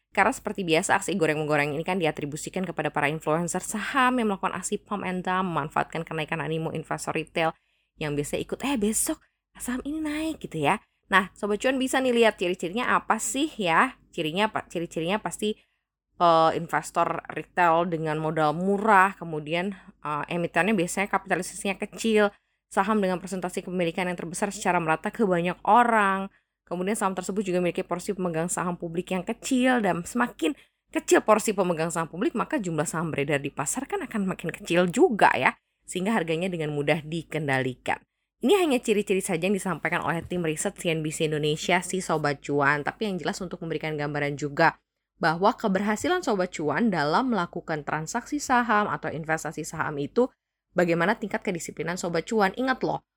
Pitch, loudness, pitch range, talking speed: 180 Hz, -26 LUFS, 160-210 Hz, 165 wpm